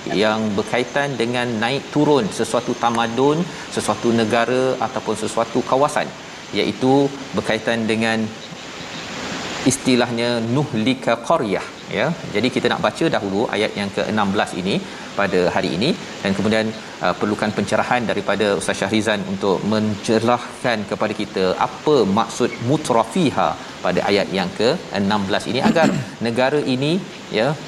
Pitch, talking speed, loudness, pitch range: 120 Hz, 115 wpm, -20 LUFS, 110-130 Hz